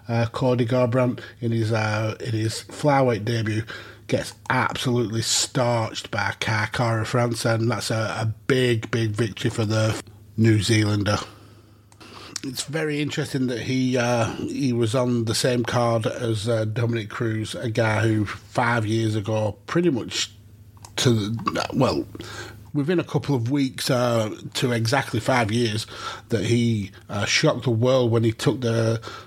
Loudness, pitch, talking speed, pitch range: -23 LUFS, 115 Hz, 150 wpm, 110-125 Hz